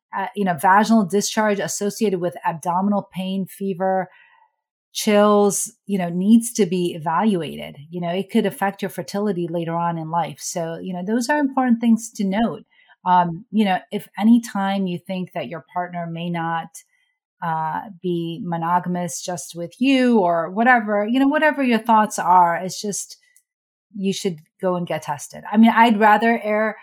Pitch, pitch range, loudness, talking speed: 195 Hz, 175-220 Hz, -20 LUFS, 165 wpm